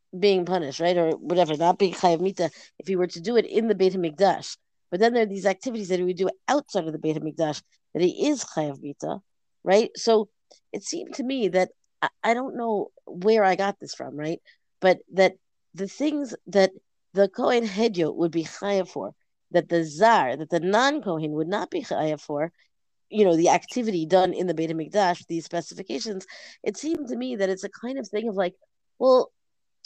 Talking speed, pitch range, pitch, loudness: 205 wpm, 170-225 Hz, 190 Hz, -25 LUFS